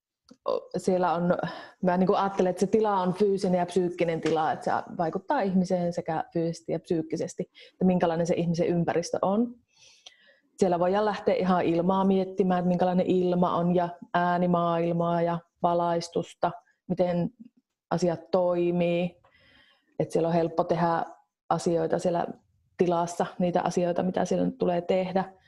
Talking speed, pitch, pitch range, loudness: 140 wpm, 180 Hz, 170-190 Hz, -27 LUFS